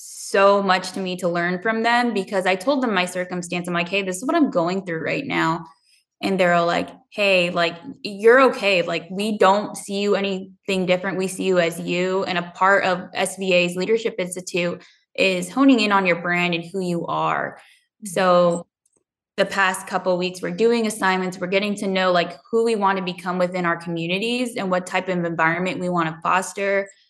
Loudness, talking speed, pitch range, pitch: -21 LUFS, 205 wpm, 175-200 Hz, 185 Hz